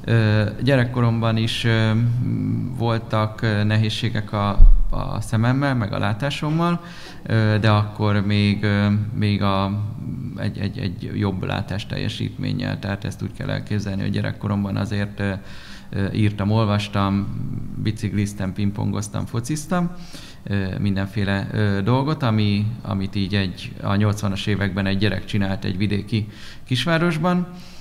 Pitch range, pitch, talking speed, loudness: 100-120 Hz, 105 Hz, 105 wpm, -22 LUFS